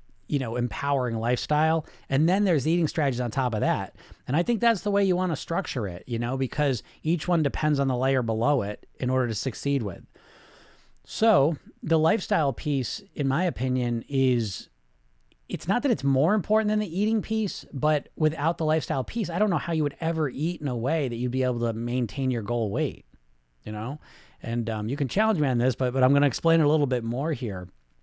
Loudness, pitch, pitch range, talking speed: -26 LUFS, 140 Hz, 120-165 Hz, 225 wpm